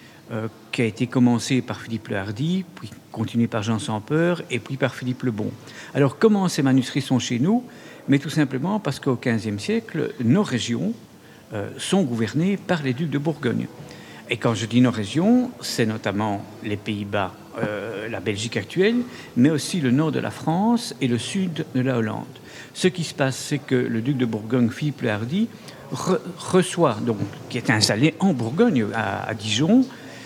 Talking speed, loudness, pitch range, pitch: 190 wpm, -23 LUFS, 115-165 Hz, 130 Hz